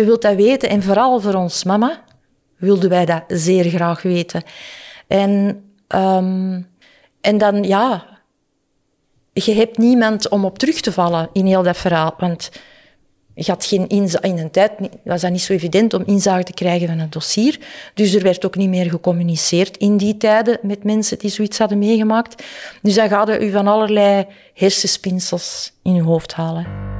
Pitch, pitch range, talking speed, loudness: 195 Hz, 180-210 Hz, 175 wpm, -16 LUFS